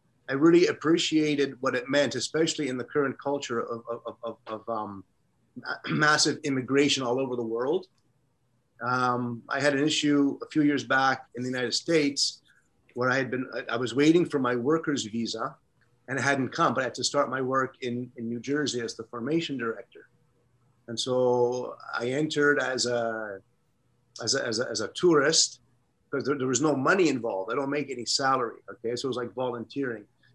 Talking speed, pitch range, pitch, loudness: 190 wpm, 120-145 Hz, 130 Hz, -27 LUFS